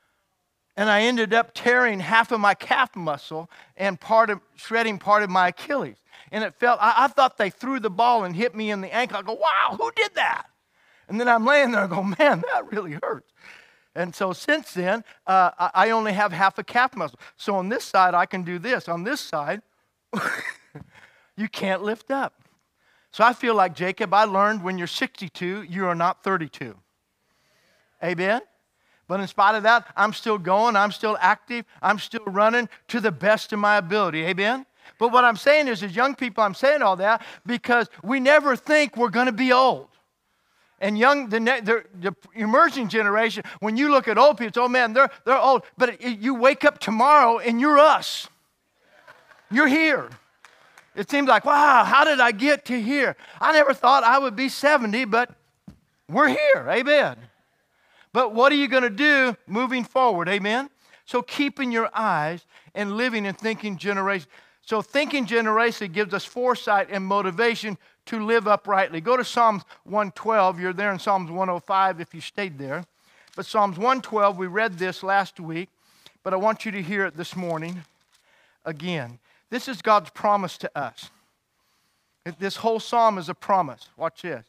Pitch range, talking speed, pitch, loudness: 190-250 Hz, 185 wpm, 220 Hz, -21 LUFS